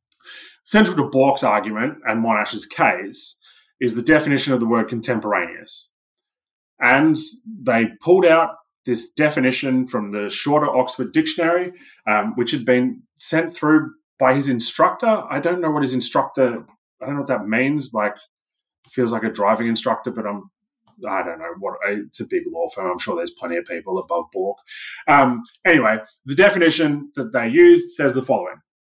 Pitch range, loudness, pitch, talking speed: 120-175 Hz, -19 LUFS, 140 Hz, 170 wpm